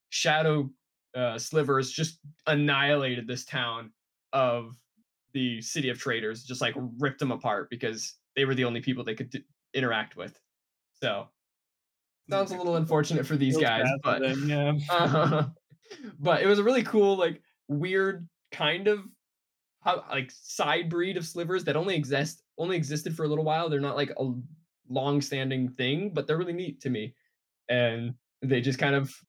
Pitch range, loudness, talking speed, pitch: 130-165 Hz, -28 LUFS, 170 wpm, 145 Hz